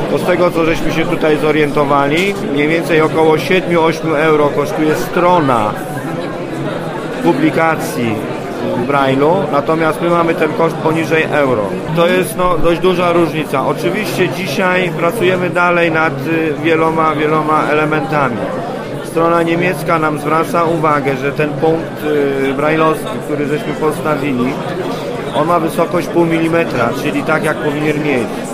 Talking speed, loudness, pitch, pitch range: 125 wpm, -14 LUFS, 160 Hz, 150-170 Hz